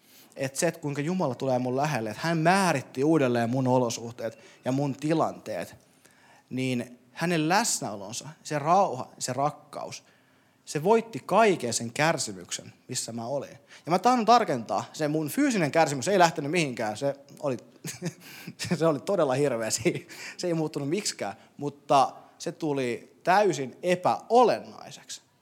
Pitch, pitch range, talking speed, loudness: 150 Hz, 130-170 Hz, 135 wpm, -27 LUFS